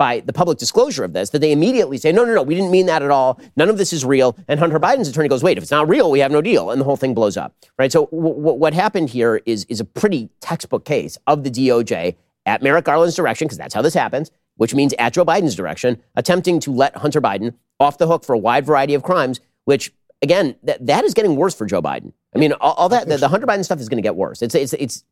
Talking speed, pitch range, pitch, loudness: 275 wpm, 130-165 Hz, 145 Hz, -17 LUFS